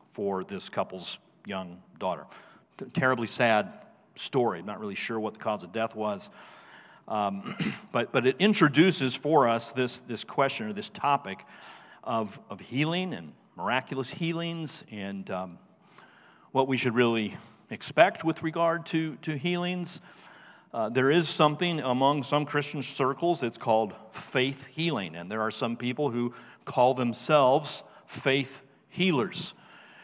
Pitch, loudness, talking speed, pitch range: 135 Hz, -28 LUFS, 140 wpm, 115-165 Hz